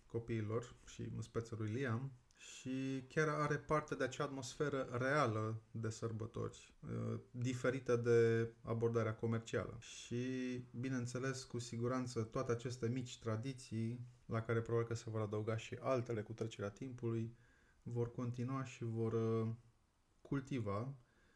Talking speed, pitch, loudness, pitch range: 125 wpm, 120 Hz, -42 LUFS, 115-130 Hz